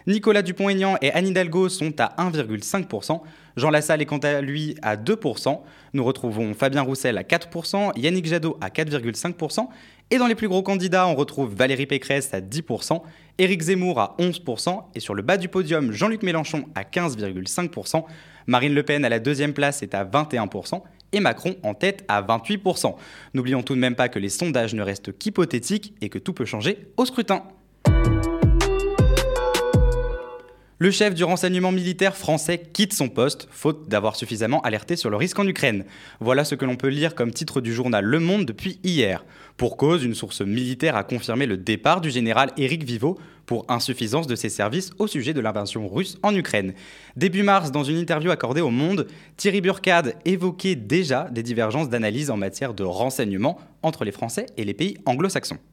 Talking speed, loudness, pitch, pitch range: 185 wpm, -23 LUFS, 150 Hz, 125-185 Hz